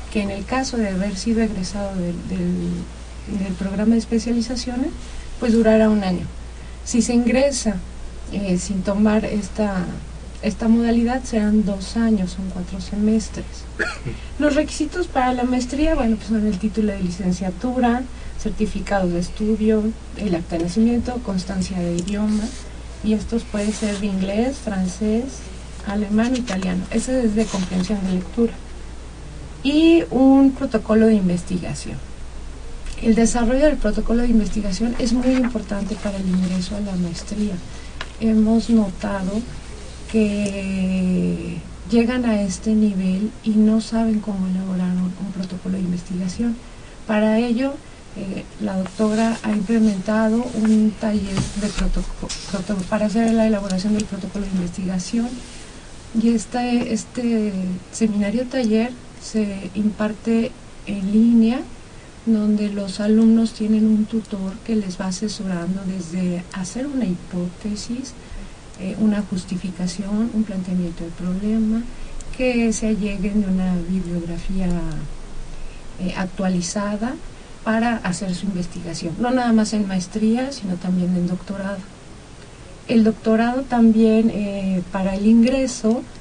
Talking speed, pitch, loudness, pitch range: 125 wpm, 210 Hz, -21 LUFS, 185-225 Hz